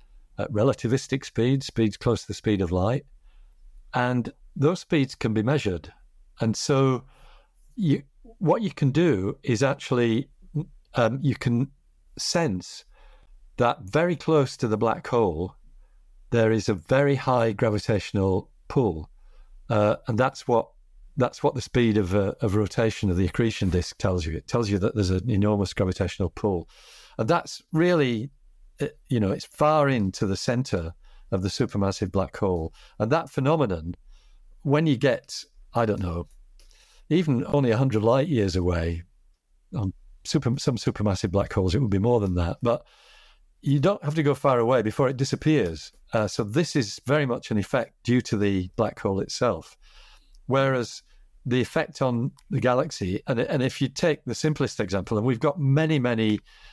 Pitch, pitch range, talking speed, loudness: 120 Hz, 100-140 Hz, 165 wpm, -25 LUFS